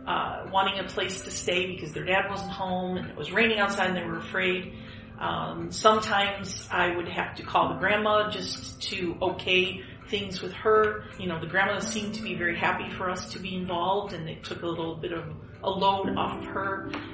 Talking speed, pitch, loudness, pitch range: 215 wpm, 190 Hz, -28 LUFS, 175-200 Hz